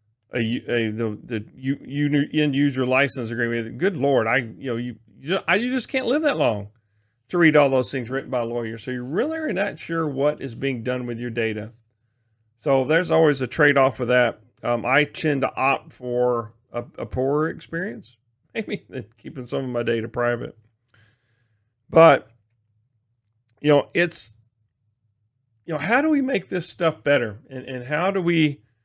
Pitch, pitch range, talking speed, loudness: 125 Hz, 115-150 Hz, 185 wpm, -22 LUFS